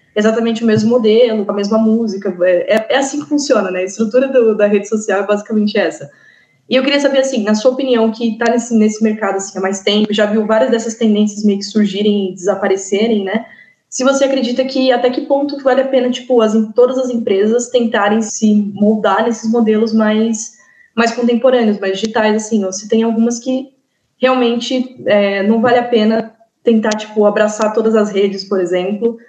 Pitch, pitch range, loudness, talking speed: 225 Hz, 210-245 Hz, -14 LUFS, 200 wpm